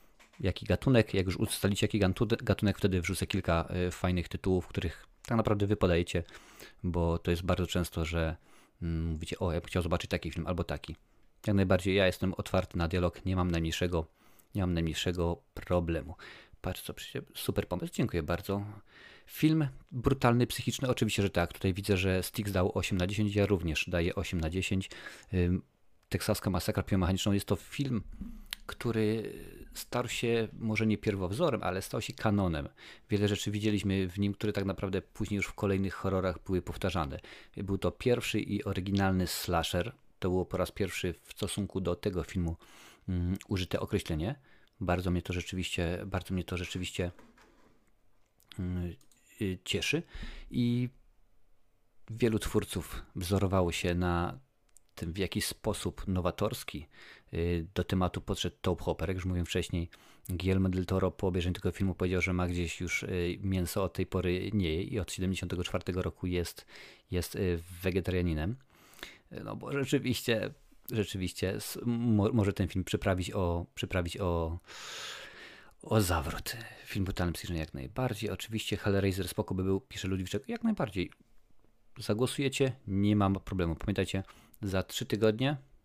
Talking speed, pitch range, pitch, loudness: 150 wpm, 90-105 Hz, 95 Hz, -33 LUFS